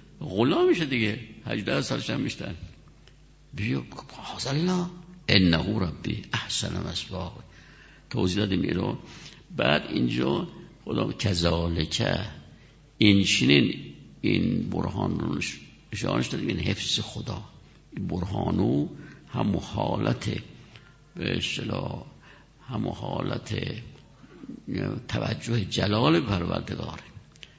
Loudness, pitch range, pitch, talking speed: -27 LUFS, 90-125 Hz, 105 Hz, 85 wpm